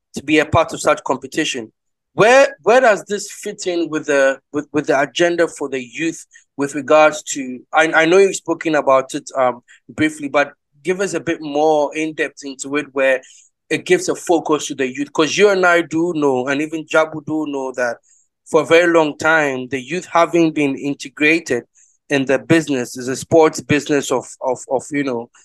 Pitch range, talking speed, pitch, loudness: 140-165 Hz, 205 wpm, 155 Hz, -17 LUFS